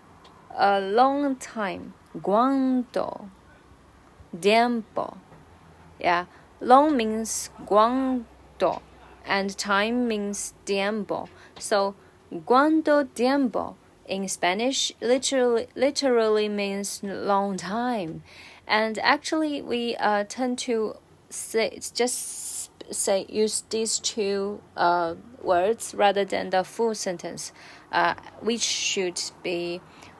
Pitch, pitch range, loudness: 215 Hz, 195-245 Hz, -25 LUFS